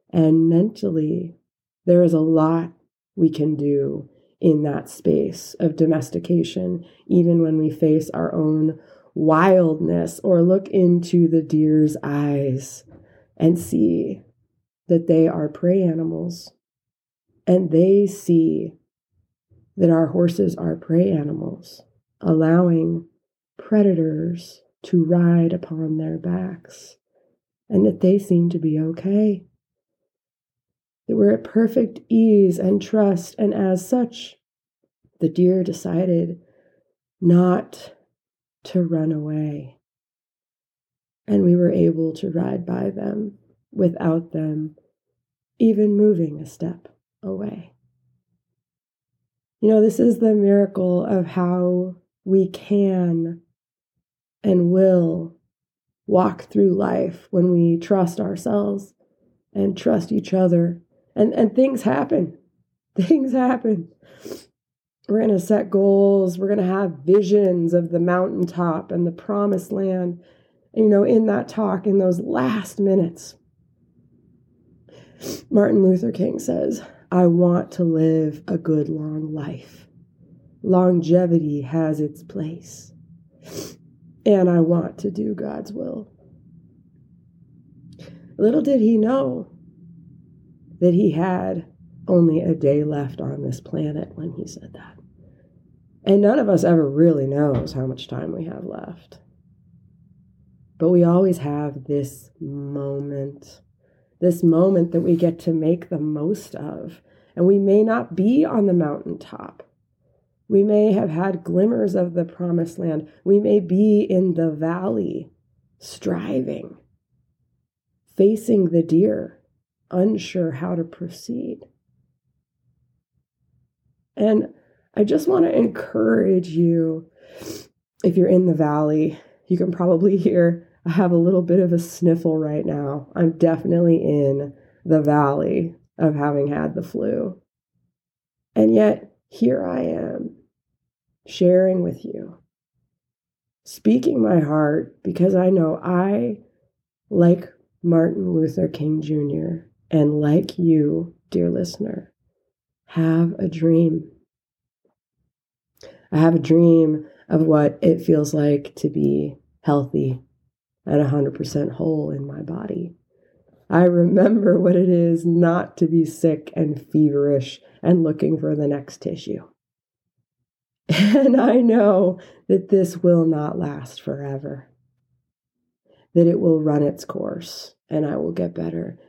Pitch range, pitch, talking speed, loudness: 155-190 Hz, 170 Hz, 120 wpm, -19 LUFS